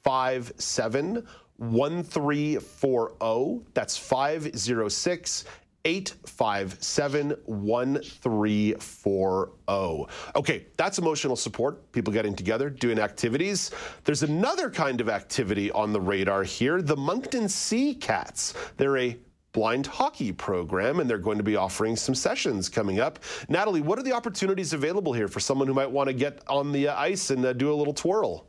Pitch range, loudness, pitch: 110-150 Hz, -27 LUFS, 130 Hz